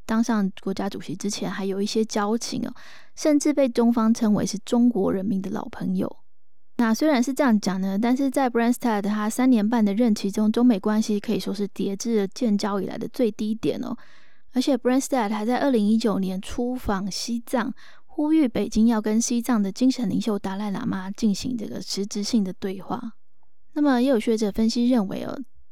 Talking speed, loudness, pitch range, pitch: 320 characters per minute, -24 LUFS, 205-245 Hz, 225 Hz